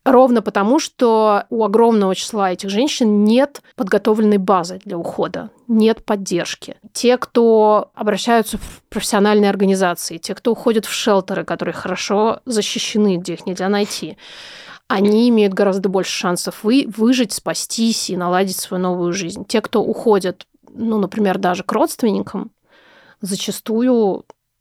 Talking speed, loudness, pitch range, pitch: 135 wpm, -17 LUFS, 190-230 Hz, 210 Hz